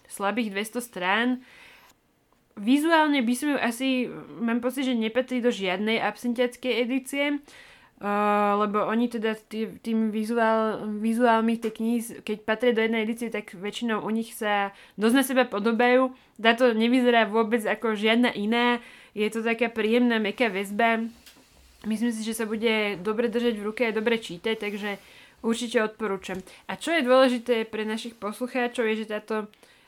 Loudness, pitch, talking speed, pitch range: -25 LUFS, 230 Hz, 155 wpm, 215-245 Hz